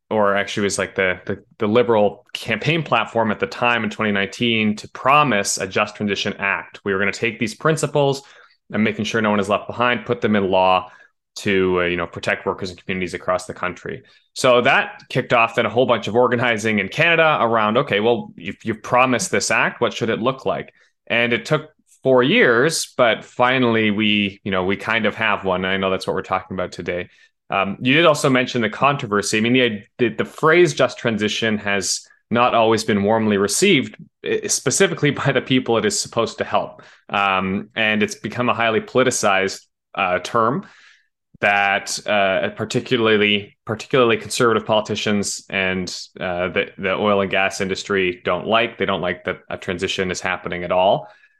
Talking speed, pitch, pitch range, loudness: 190 wpm, 110 Hz, 100-125 Hz, -19 LUFS